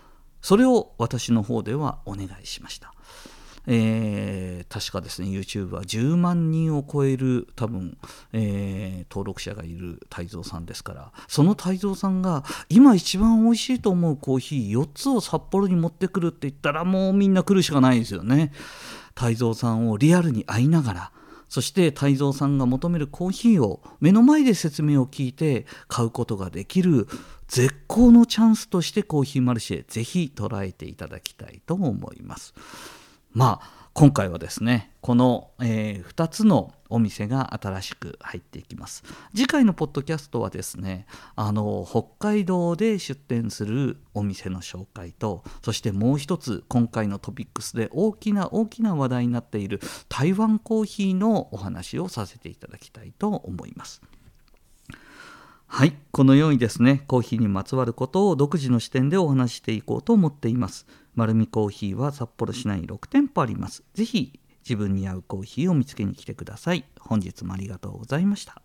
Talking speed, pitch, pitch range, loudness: 345 characters per minute, 130 Hz, 105-170 Hz, -23 LUFS